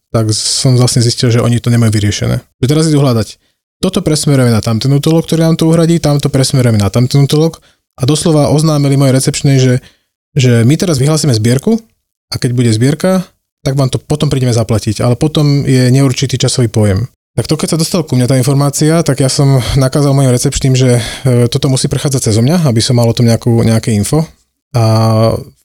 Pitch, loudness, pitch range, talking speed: 130 Hz, -11 LUFS, 120-150 Hz, 195 wpm